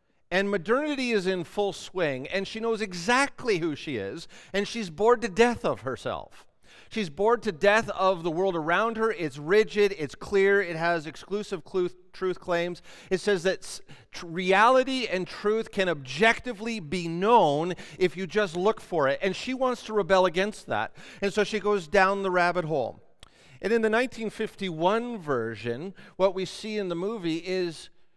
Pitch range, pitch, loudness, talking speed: 180-220 Hz, 195 Hz, -27 LUFS, 180 wpm